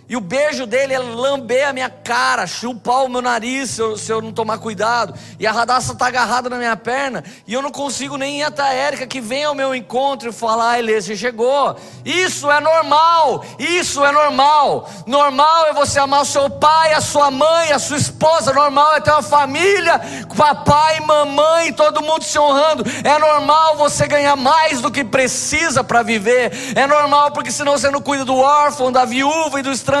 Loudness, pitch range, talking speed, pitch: -15 LUFS, 250-295 Hz, 205 wpm, 280 Hz